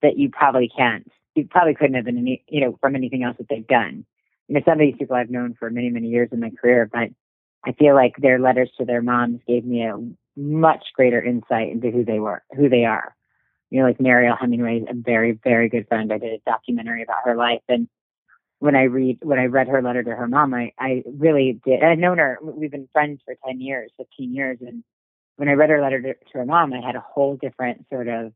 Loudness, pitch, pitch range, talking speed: -20 LUFS, 125 Hz, 120-135 Hz, 245 wpm